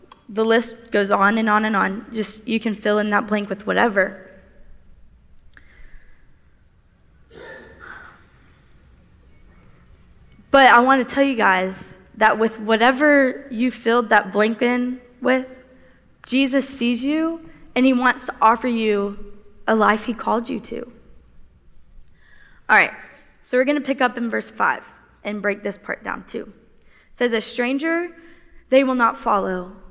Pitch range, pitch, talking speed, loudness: 205-255 Hz, 225 Hz, 145 wpm, -19 LUFS